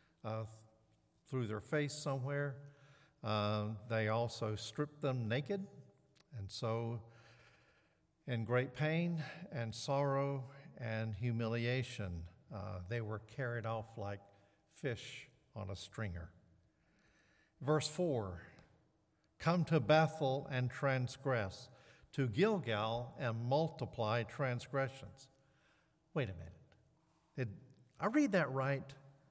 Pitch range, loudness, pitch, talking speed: 110-145 Hz, -39 LUFS, 125 Hz, 100 wpm